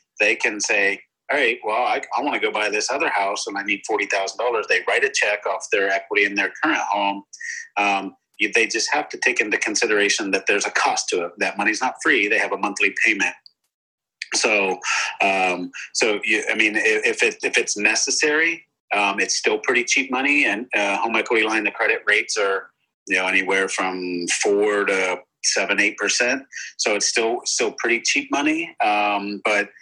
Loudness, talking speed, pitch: -20 LUFS, 200 wpm, 145 Hz